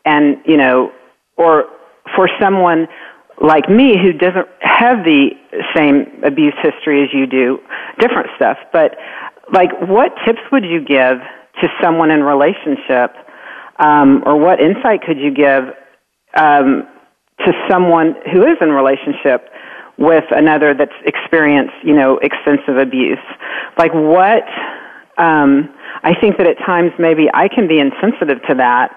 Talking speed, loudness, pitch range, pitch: 140 wpm, -12 LUFS, 140-175 Hz, 155 Hz